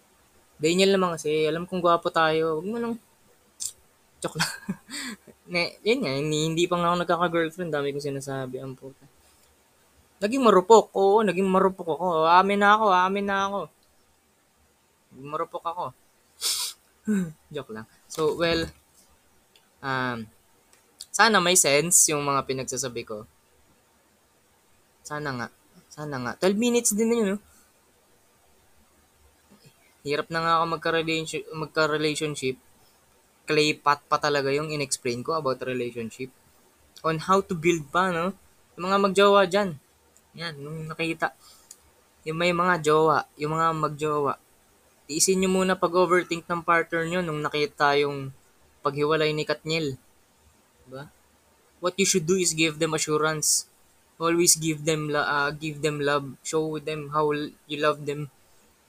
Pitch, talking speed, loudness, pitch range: 155 Hz, 140 wpm, -24 LUFS, 145-180 Hz